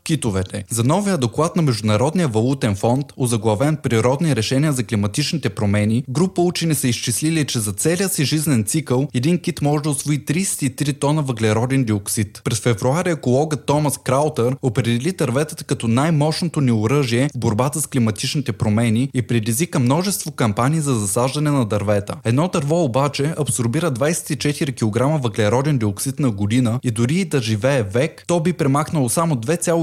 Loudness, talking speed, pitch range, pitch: -19 LUFS, 155 wpm, 120-155 Hz, 135 Hz